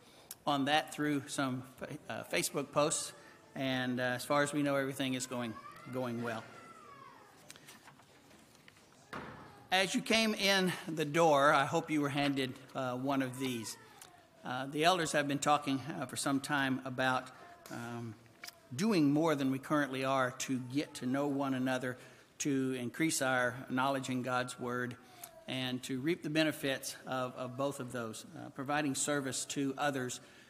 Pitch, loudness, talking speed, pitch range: 135 Hz, -34 LUFS, 155 wpm, 125-145 Hz